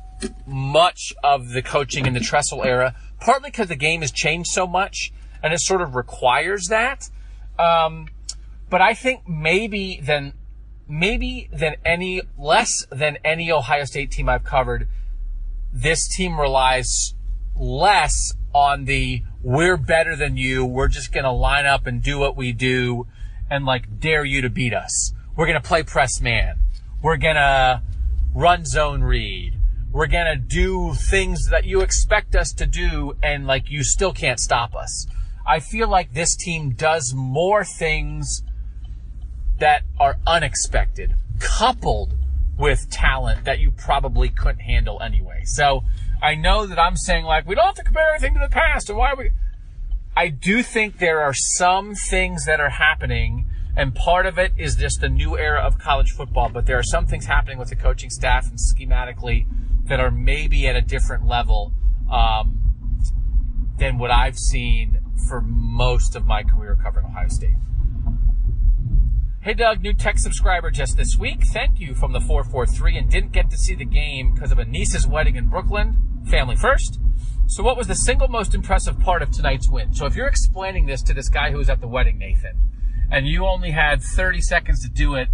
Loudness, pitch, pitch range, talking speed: -20 LUFS, 130 Hz, 110-160 Hz, 175 wpm